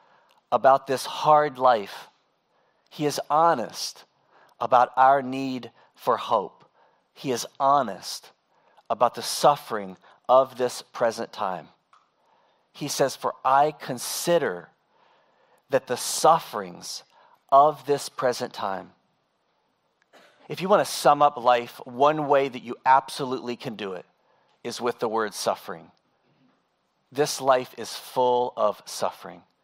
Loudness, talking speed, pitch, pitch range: -24 LUFS, 120 wpm, 130 Hz, 125-145 Hz